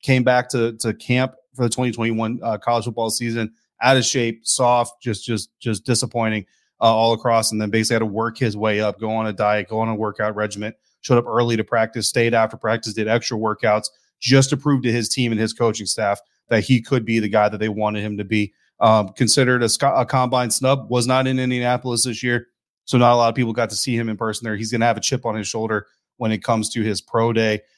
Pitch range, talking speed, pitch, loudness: 110-120 Hz, 250 wpm, 115 Hz, -20 LUFS